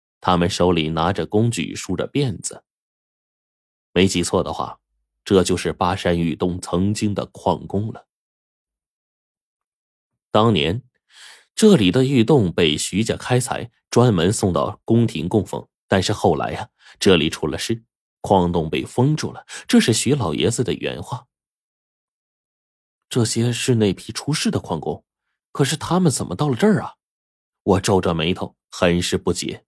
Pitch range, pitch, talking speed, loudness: 85-120 Hz, 100 Hz, 215 characters per minute, -20 LUFS